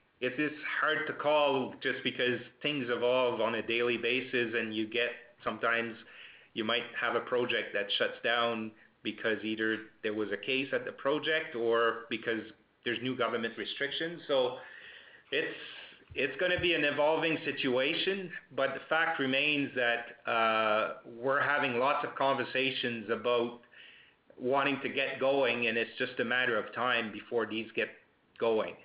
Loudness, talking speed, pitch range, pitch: -31 LUFS, 160 wpm, 115-140 Hz, 125 Hz